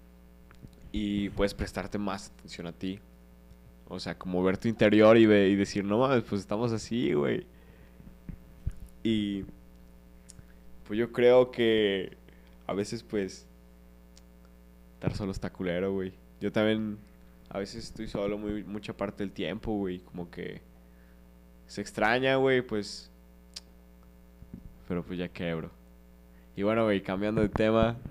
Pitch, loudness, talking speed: 95 Hz, -29 LUFS, 135 wpm